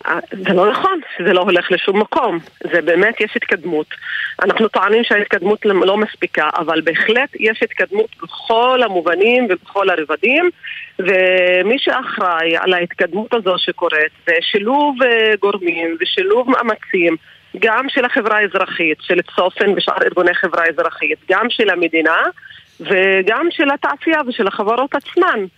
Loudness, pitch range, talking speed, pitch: -15 LUFS, 175-240 Hz, 130 wpm, 200 Hz